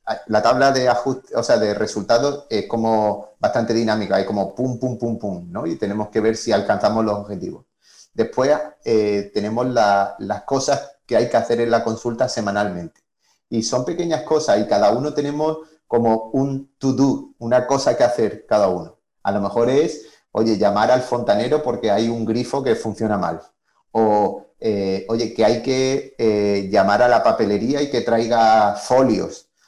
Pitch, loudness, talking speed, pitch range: 115 Hz, -19 LUFS, 180 wpm, 105-130 Hz